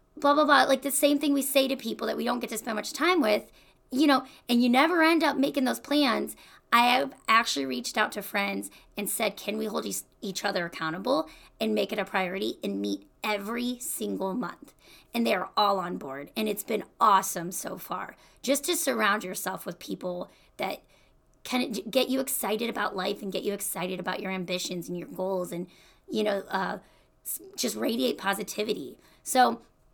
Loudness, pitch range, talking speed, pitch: -28 LUFS, 190-265 Hz, 195 wpm, 215 Hz